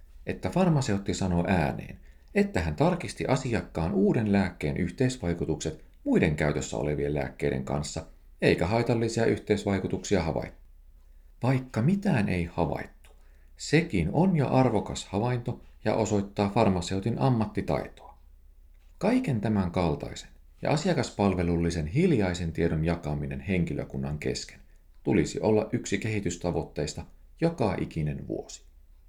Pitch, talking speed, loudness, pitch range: 90 Hz, 105 wpm, -28 LUFS, 70-110 Hz